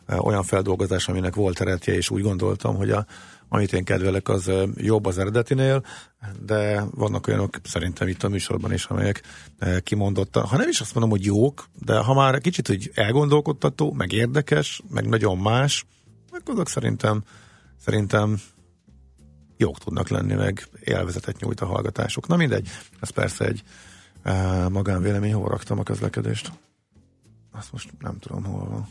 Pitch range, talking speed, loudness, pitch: 95-120 Hz, 150 wpm, -24 LUFS, 105 Hz